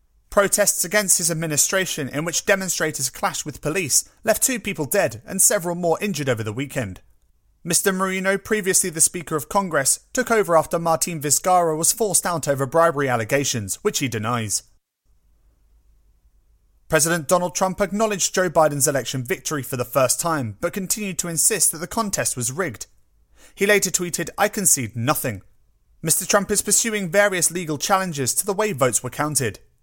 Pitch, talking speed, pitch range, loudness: 170 Hz, 165 wpm, 140-195 Hz, -20 LUFS